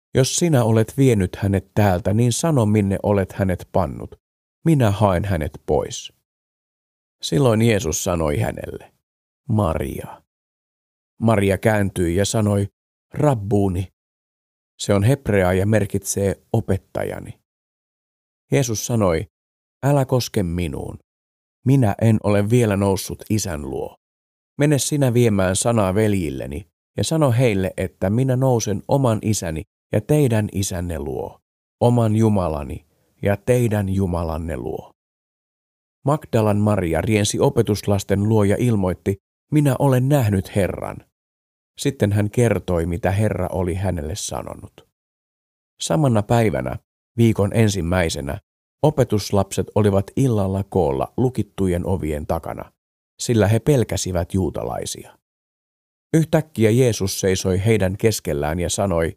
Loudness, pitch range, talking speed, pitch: -20 LUFS, 90-115 Hz, 110 wpm, 100 Hz